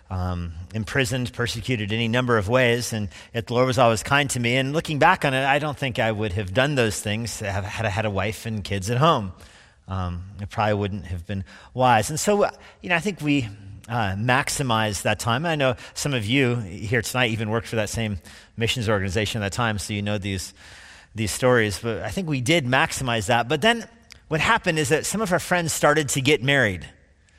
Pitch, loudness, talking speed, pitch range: 115 Hz, -23 LUFS, 220 wpm, 105-135 Hz